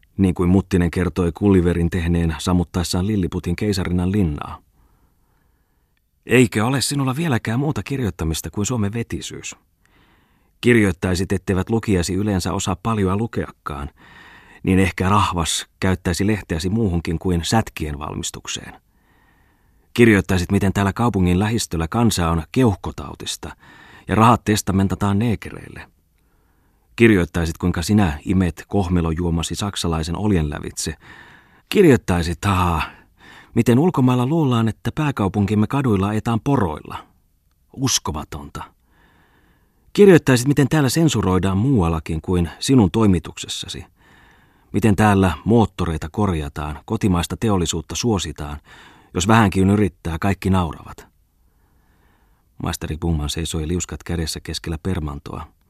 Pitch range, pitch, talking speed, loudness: 85-105 Hz, 95 Hz, 100 wpm, -19 LUFS